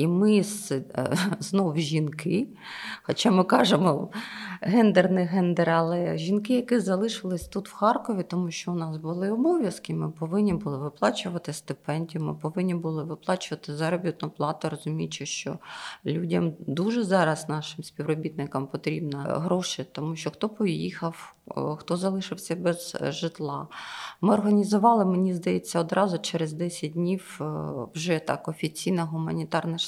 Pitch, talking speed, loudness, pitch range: 170 Hz, 125 wpm, -27 LUFS, 155-190 Hz